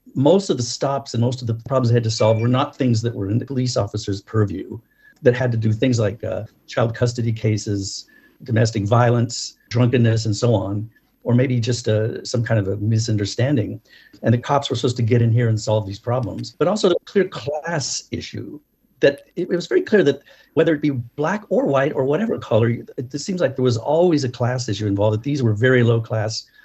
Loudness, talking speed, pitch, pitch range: -20 LUFS, 220 wpm, 120 Hz, 110-130 Hz